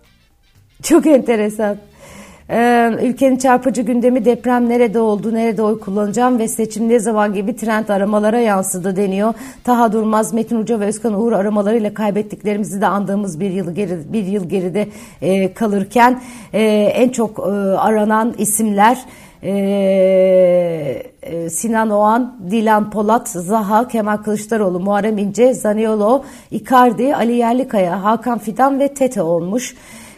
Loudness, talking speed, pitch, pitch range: -15 LUFS, 120 wpm, 215 Hz, 200-235 Hz